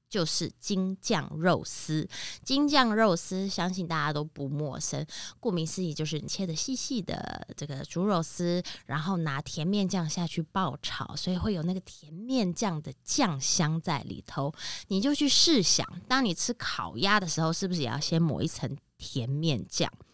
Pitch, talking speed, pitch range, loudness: 170 Hz, 255 characters per minute, 150-195 Hz, -29 LUFS